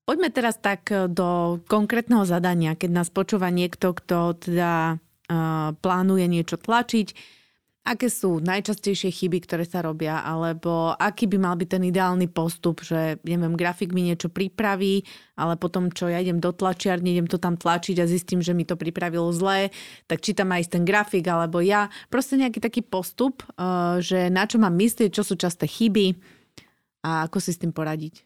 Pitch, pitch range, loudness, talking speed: 180 Hz, 170-200 Hz, -24 LUFS, 180 wpm